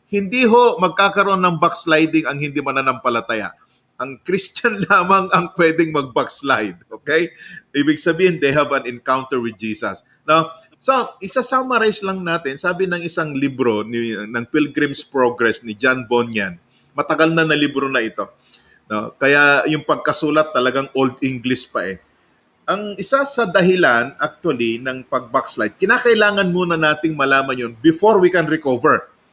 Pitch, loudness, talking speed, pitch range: 155 Hz, -17 LUFS, 145 wpm, 130-185 Hz